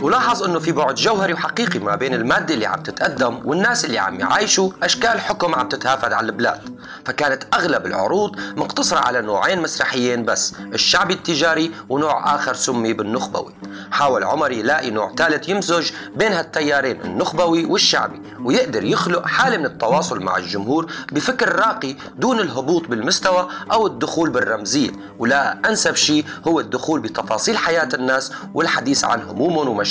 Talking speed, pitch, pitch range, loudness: 145 wpm, 165 Hz, 130-185 Hz, -18 LUFS